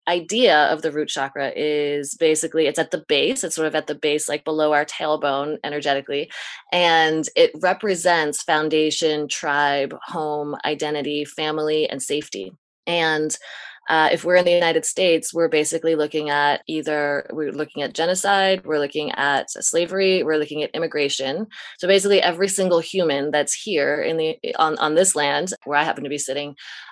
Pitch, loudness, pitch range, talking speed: 155 Hz, -20 LUFS, 145-175 Hz, 170 wpm